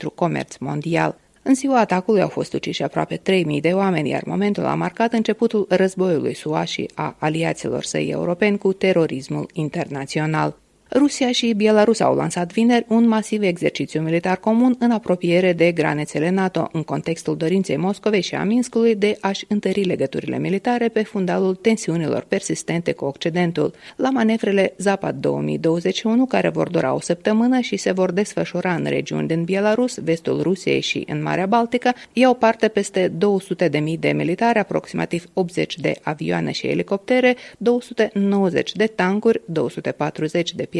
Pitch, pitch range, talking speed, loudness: 190 Hz, 165-220 Hz, 150 wpm, -20 LUFS